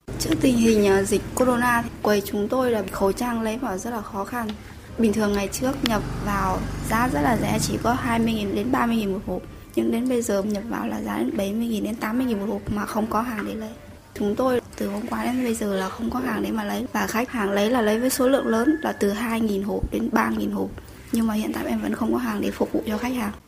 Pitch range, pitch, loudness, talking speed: 205-245 Hz, 220 Hz, -24 LUFS, 260 wpm